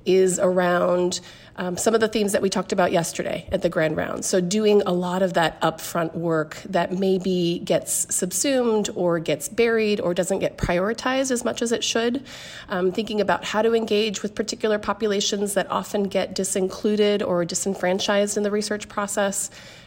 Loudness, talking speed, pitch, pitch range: -23 LUFS, 180 wpm, 195 Hz, 180-210 Hz